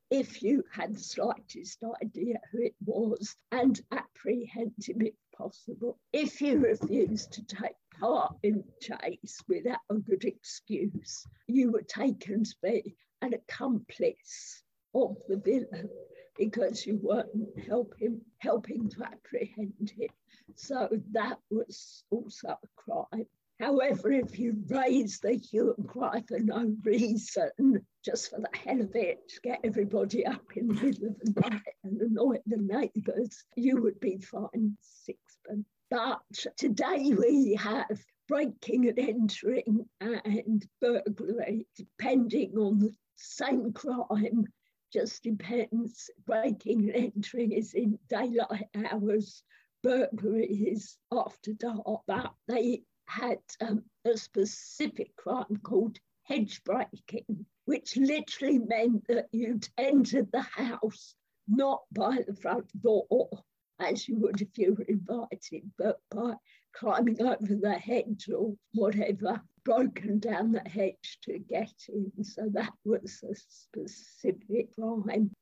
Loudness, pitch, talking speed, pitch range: -31 LUFS, 225 Hz, 130 wpm, 210-240 Hz